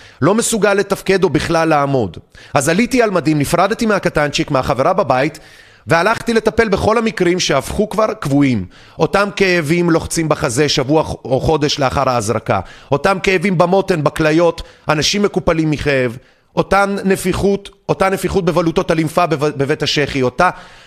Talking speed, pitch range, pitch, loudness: 130 wpm, 145-195 Hz, 165 Hz, -15 LUFS